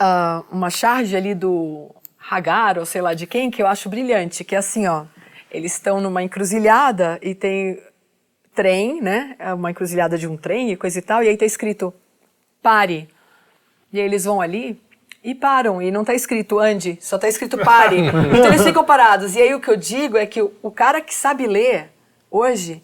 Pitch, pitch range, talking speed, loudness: 205 Hz, 180-235 Hz, 200 wpm, -17 LUFS